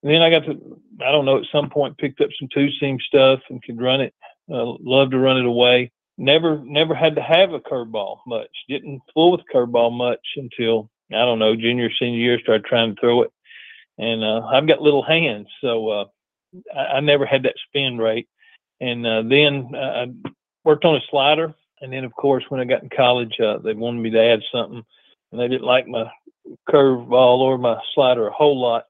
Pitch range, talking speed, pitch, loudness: 120-150 Hz, 215 wpm, 130 Hz, -19 LUFS